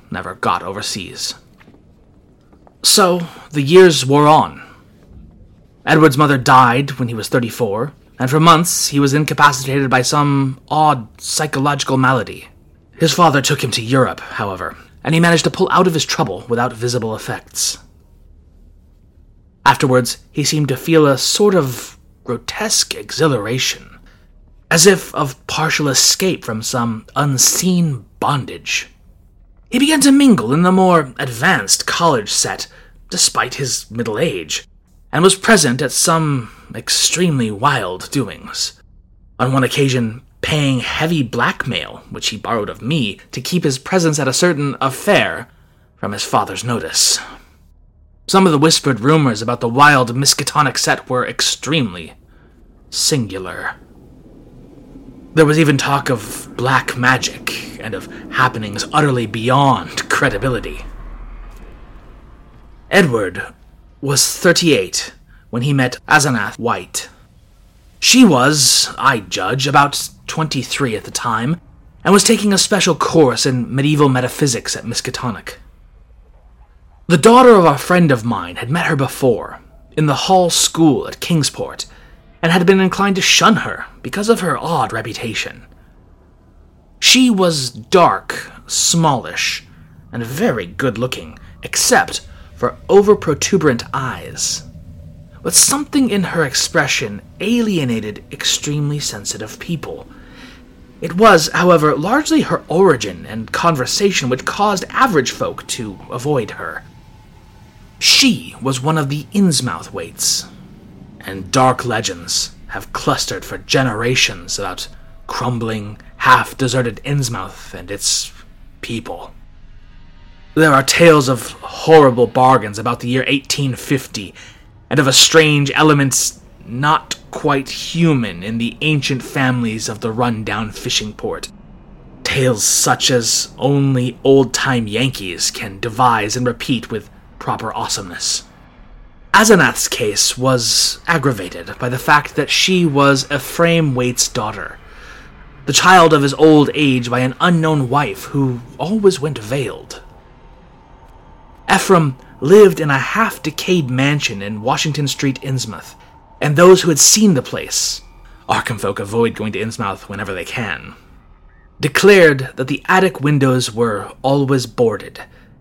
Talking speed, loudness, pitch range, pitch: 130 wpm, -14 LUFS, 120-160 Hz, 135 Hz